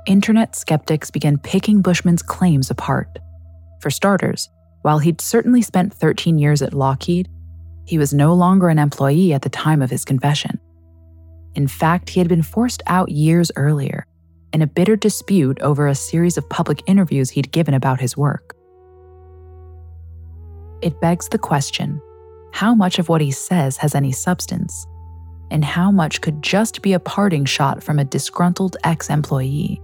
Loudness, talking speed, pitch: -17 LUFS, 160 wpm, 150 Hz